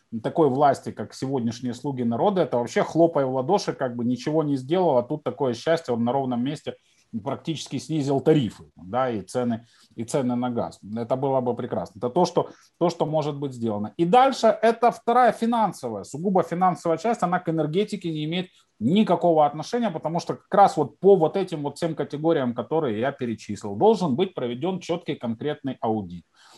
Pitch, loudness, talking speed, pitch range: 155 Hz, -24 LUFS, 185 wpm, 125-175 Hz